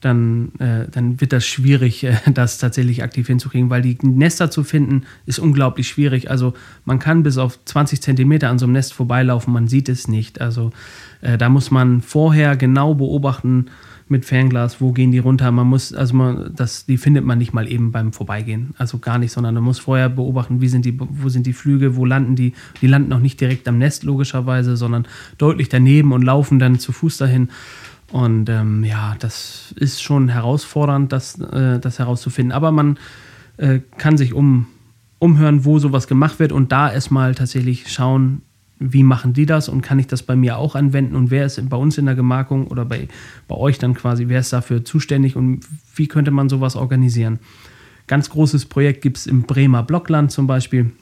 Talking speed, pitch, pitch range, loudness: 200 wpm, 130 Hz, 125-140 Hz, -16 LUFS